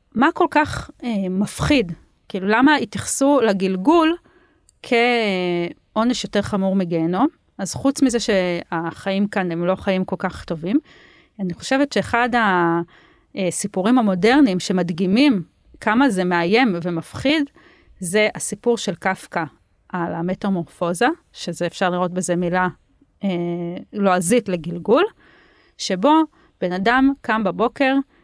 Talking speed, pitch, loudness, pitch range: 115 wpm, 200 Hz, -20 LUFS, 180-250 Hz